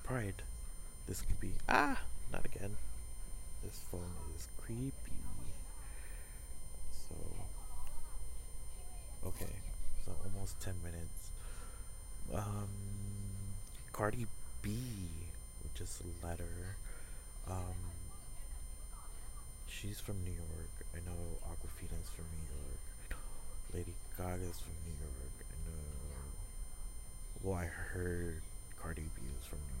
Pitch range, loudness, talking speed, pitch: 70-95 Hz, -46 LUFS, 105 wpm, 85 Hz